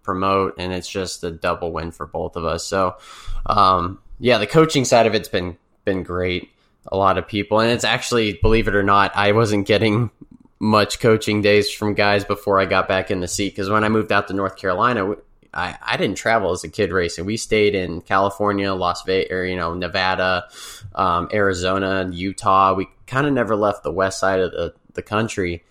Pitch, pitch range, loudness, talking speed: 95 Hz, 90-105 Hz, -19 LUFS, 210 wpm